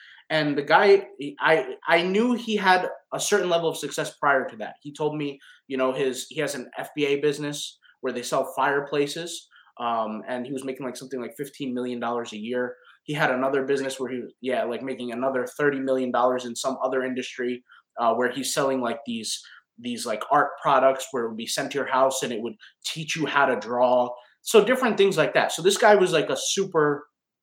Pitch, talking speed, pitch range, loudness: 140 Hz, 215 wpm, 125-160 Hz, -24 LUFS